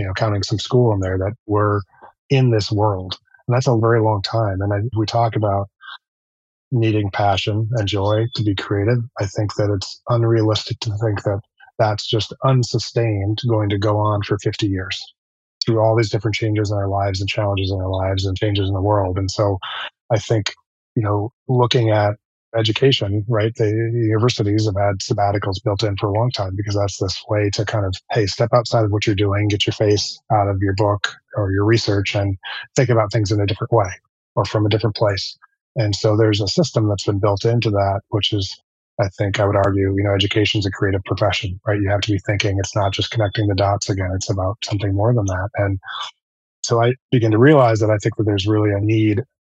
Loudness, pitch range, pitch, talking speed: -19 LUFS, 100-115 Hz, 105 Hz, 220 wpm